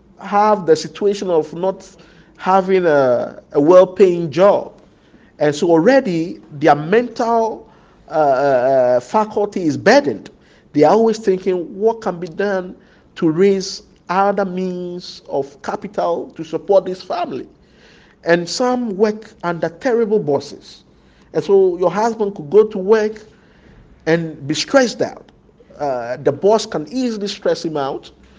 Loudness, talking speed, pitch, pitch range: -17 LUFS, 135 wpm, 195 Hz, 170-220 Hz